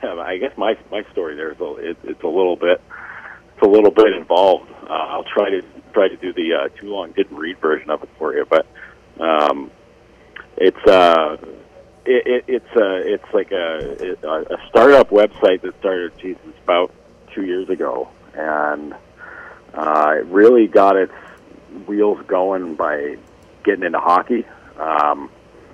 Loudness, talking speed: -17 LUFS, 165 wpm